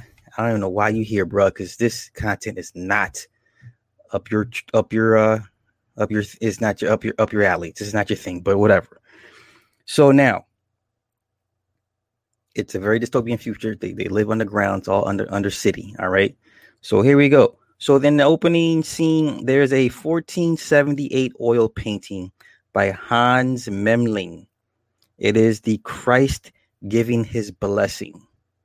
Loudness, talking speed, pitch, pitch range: -19 LUFS, 170 wpm, 110 Hz, 100-120 Hz